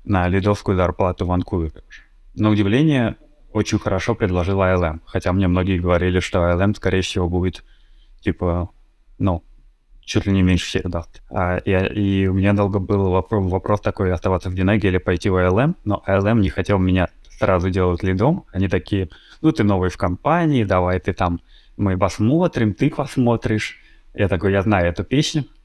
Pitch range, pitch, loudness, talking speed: 90-105 Hz, 95 Hz, -20 LUFS, 170 wpm